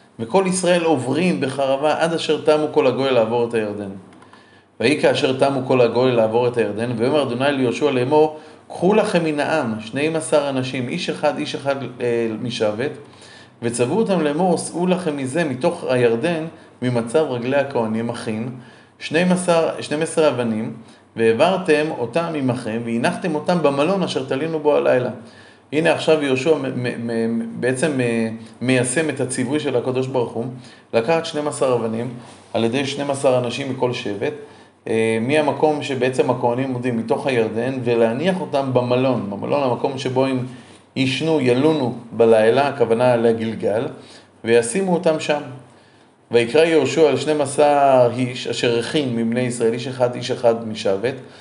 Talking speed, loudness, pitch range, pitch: 140 wpm, -19 LUFS, 120-150 Hz, 130 Hz